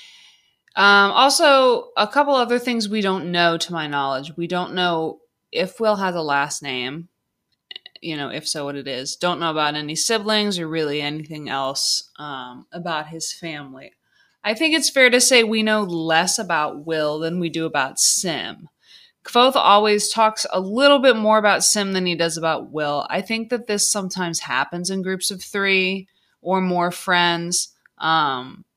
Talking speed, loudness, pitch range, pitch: 175 wpm, -19 LUFS, 160-215 Hz, 180 Hz